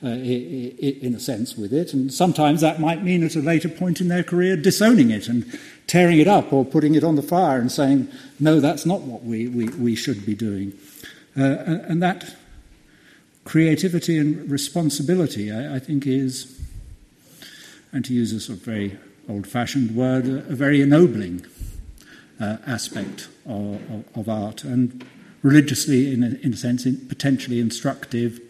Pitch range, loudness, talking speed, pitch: 120-160 Hz, -21 LUFS, 170 wpm, 135 Hz